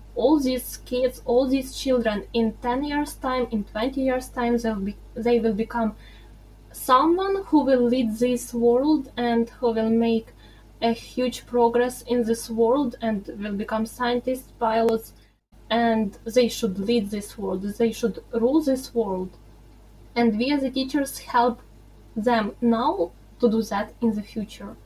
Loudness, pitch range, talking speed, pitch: -24 LUFS, 215-250 Hz, 155 wpm, 235 Hz